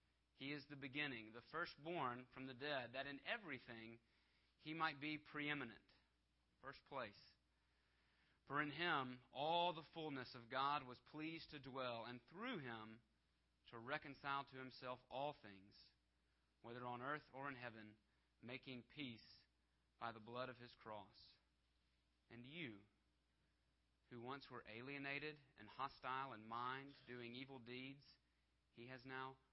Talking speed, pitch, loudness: 140 wpm, 125 Hz, -51 LUFS